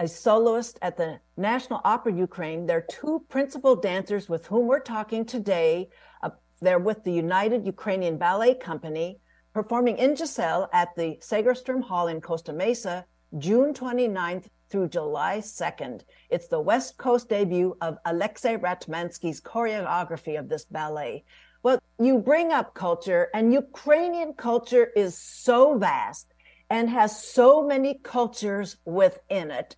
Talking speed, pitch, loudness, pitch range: 140 wpm, 215 Hz, -25 LUFS, 175-250 Hz